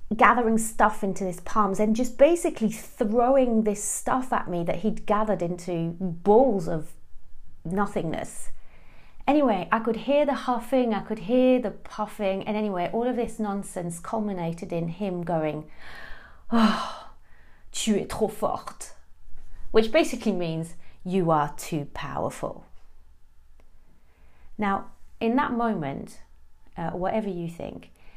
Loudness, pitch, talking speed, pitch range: -26 LUFS, 200 Hz, 130 wpm, 165-225 Hz